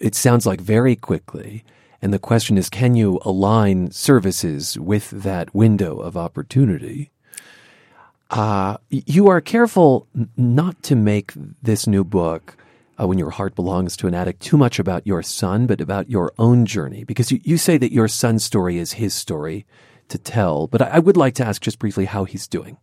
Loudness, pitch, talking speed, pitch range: -18 LUFS, 110 Hz, 185 wpm, 95-130 Hz